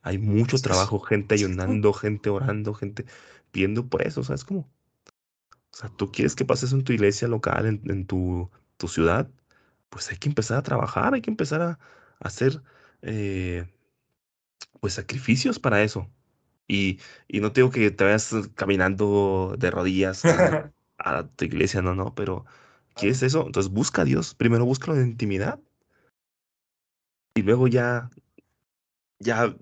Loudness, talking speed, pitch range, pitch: -24 LUFS, 155 wpm, 95-130 Hz, 110 Hz